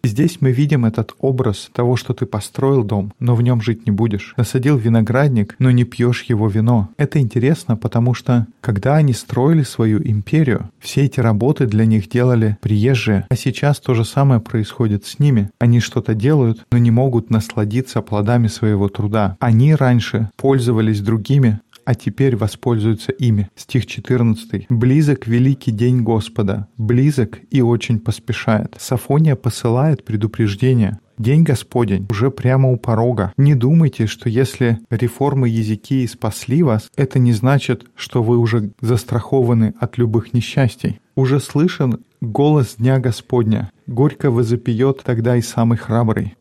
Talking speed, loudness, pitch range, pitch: 145 wpm, -17 LUFS, 110-130 Hz, 120 Hz